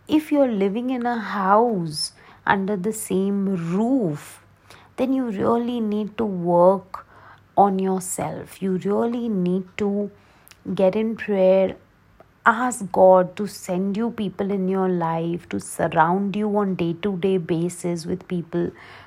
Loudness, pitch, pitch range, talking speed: -22 LUFS, 195 Hz, 175-210 Hz, 140 wpm